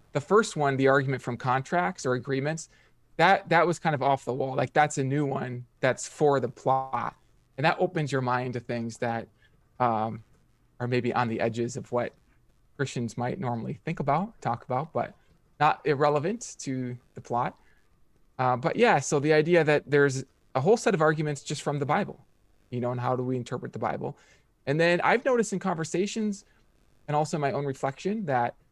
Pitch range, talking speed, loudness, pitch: 125-160 Hz, 195 wpm, -27 LUFS, 140 Hz